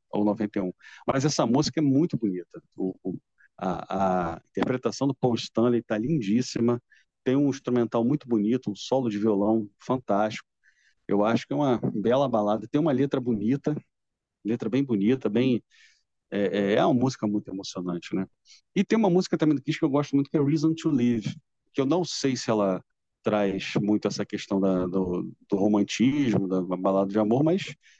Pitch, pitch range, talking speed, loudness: 115 Hz, 105-140 Hz, 180 wpm, -26 LUFS